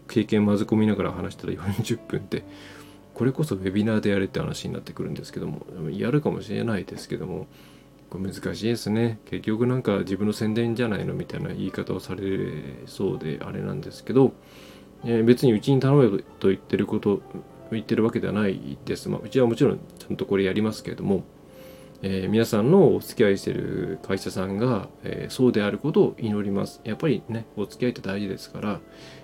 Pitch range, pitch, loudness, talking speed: 95-115 Hz, 105 Hz, -25 LUFS, 410 characters per minute